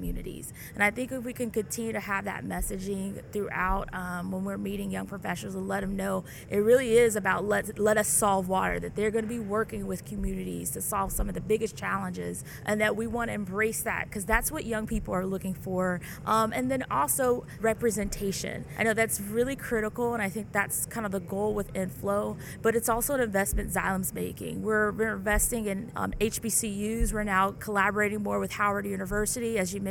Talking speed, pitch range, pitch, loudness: 215 wpm, 190-220 Hz, 205 Hz, -29 LUFS